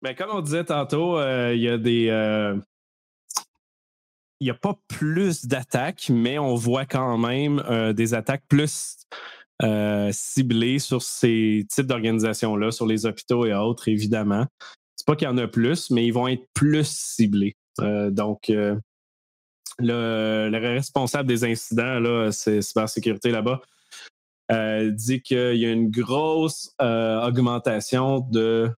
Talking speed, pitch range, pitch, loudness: 150 wpm, 110-130 Hz, 120 Hz, -23 LUFS